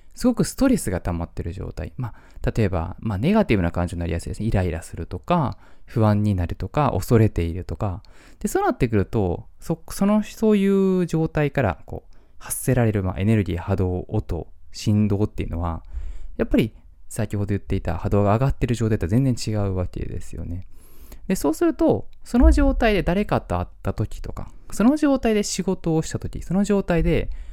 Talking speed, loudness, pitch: 385 characters per minute, -23 LUFS, 105 Hz